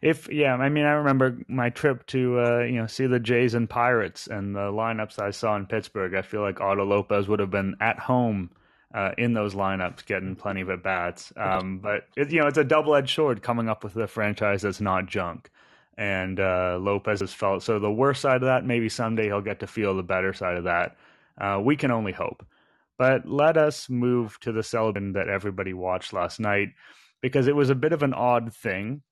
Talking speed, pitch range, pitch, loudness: 225 wpm, 100-125 Hz, 110 Hz, -25 LUFS